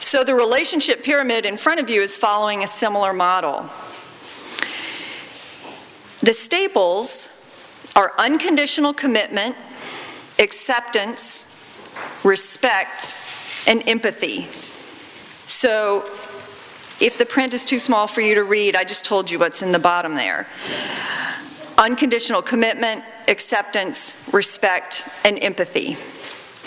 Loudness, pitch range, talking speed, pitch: -18 LUFS, 200-260 Hz, 110 wpm, 220 Hz